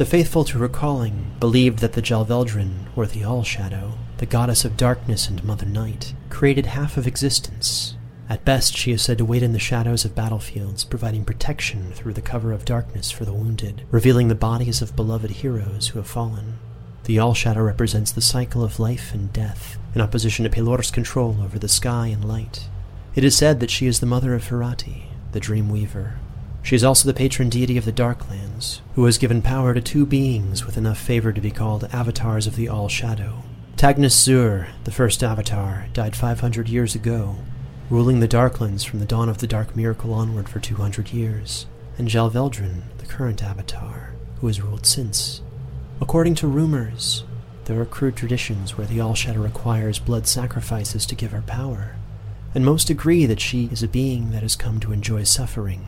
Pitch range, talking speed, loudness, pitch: 110-125 Hz, 190 wpm, -21 LUFS, 115 Hz